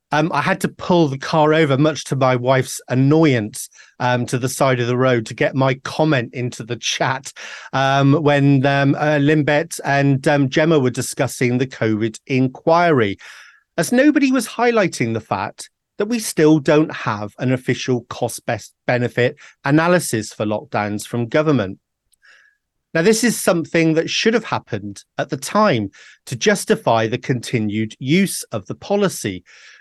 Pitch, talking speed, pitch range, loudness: 140 Hz, 155 wpm, 125-160 Hz, -18 LUFS